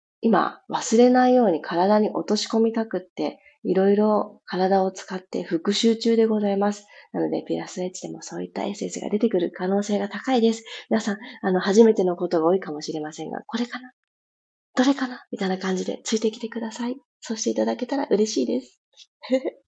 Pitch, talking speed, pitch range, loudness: 205 Hz, 405 characters per minute, 185-230 Hz, -23 LUFS